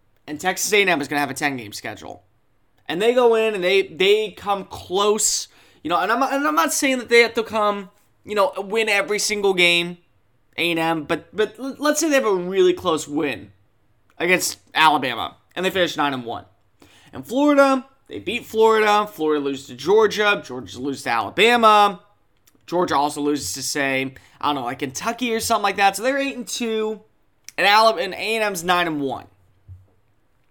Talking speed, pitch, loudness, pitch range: 185 wpm, 185 Hz, -20 LUFS, 140-220 Hz